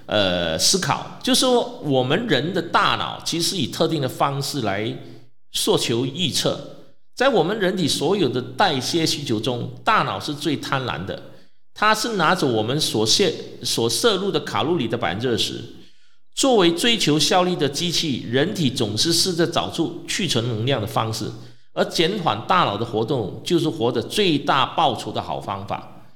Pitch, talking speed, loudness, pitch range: 145 Hz, 250 characters per minute, -21 LUFS, 115-170 Hz